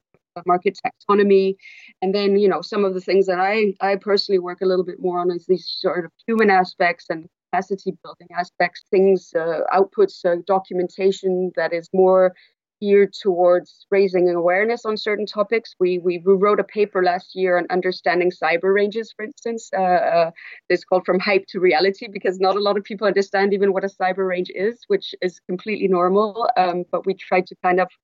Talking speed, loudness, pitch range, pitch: 195 wpm, -20 LUFS, 180-200 Hz, 190 Hz